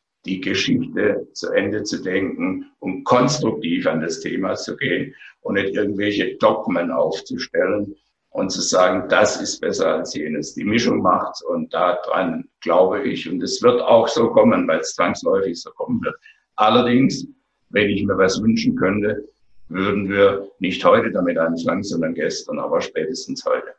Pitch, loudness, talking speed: 275 Hz, -20 LUFS, 160 wpm